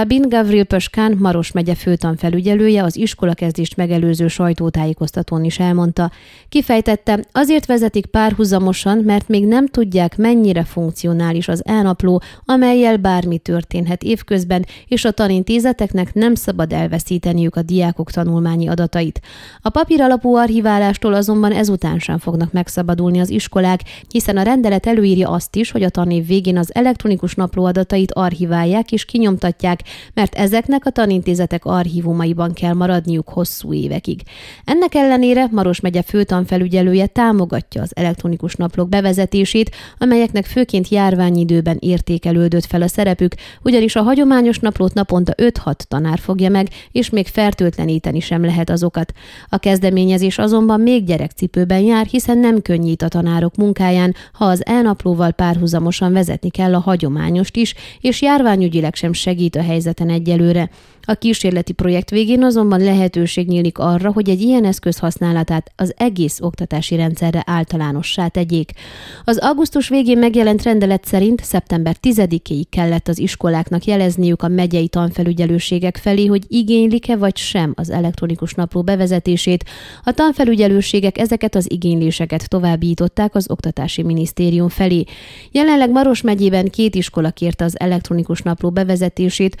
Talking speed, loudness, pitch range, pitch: 130 wpm, -15 LUFS, 170-215 Hz, 185 Hz